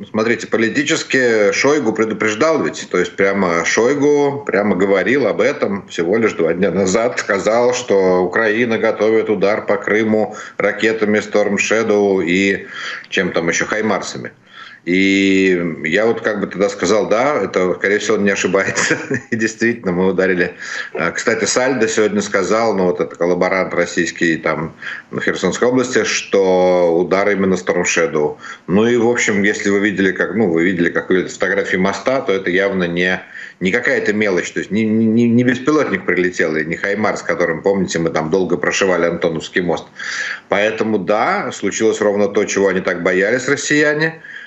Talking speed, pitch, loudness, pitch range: 160 wpm, 100 Hz, -16 LUFS, 95-110 Hz